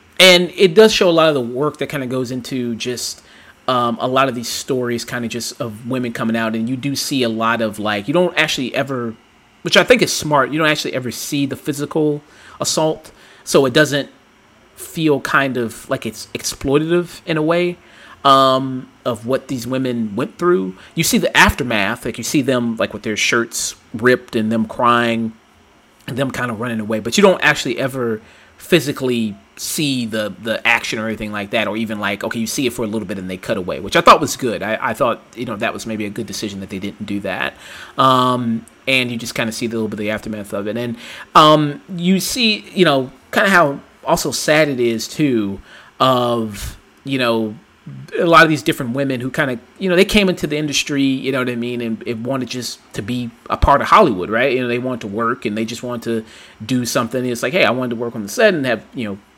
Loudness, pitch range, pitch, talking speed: -17 LUFS, 115-145 Hz, 125 Hz, 235 wpm